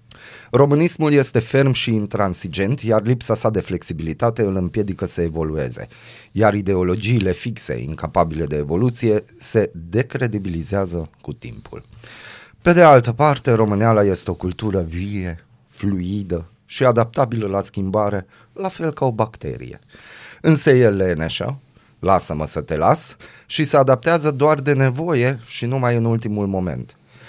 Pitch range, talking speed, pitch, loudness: 95-130 Hz, 135 wpm, 110 Hz, -19 LUFS